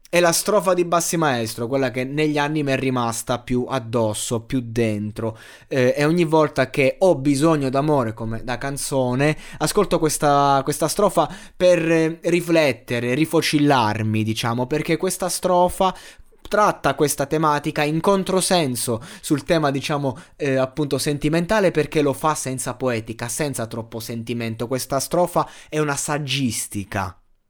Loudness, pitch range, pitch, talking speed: -21 LUFS, 125-160 Hz, 145 Hz, 135 wpm